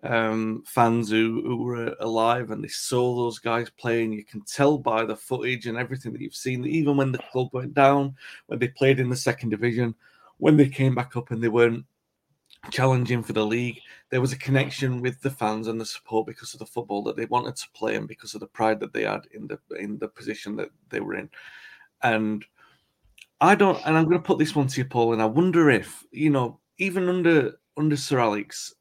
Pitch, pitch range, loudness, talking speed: 125 Hz, 115-135 Hz, -24 LUFS, 225 wpm